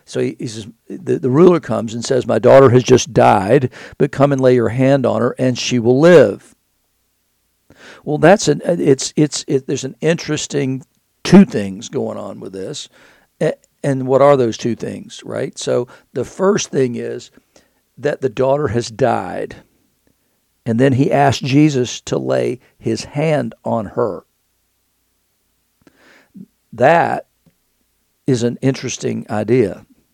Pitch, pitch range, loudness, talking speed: 130 Hz, 115-140 Hz, -15 LUFS, 145 wpm